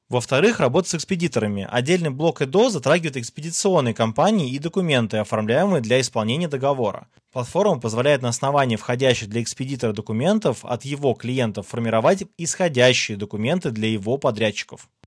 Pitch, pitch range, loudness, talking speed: 130 Hz, 115-165 Hz, -21 LUFS, 130 wpm